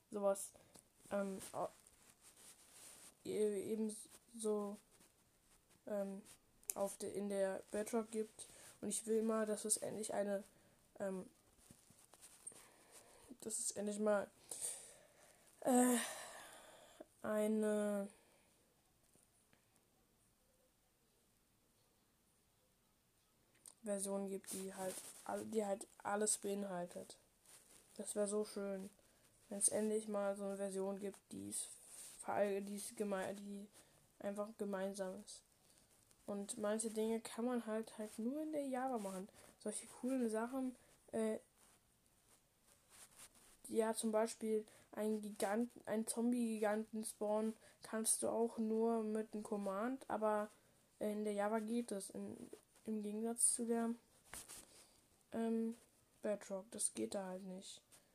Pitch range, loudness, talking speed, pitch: 200-225 Hz, -43 LUFS, 105 wpm, 210 Hz